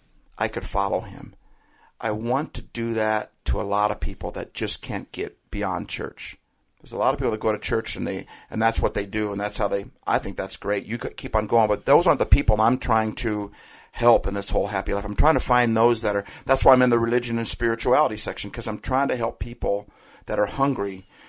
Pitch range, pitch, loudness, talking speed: 105-120 Hz, 110 Hz, -23 LUFS, 250 wpm